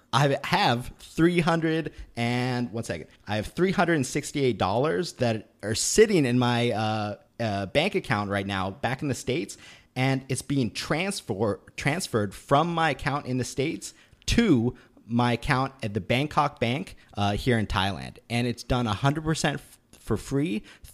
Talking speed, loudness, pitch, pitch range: 165 wpm, -26 LUFS, 125 Hz, 115-145 Hz